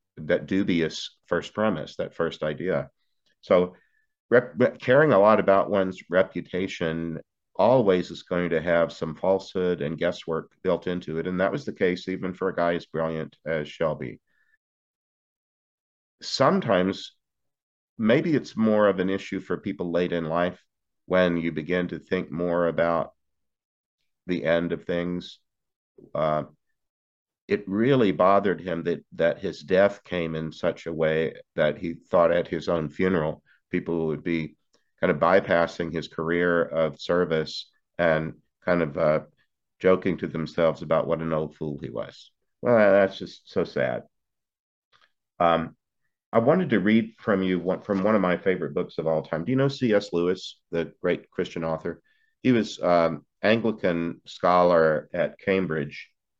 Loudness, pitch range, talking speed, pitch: -25 LUFS, 80-95 Hz, 155 wpm, 85 Hz